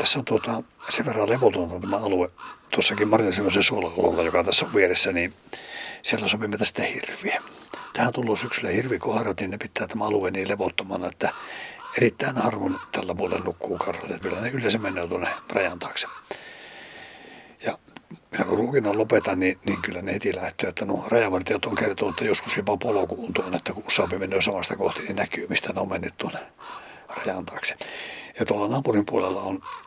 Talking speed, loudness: 170 wpm, -24 LUFS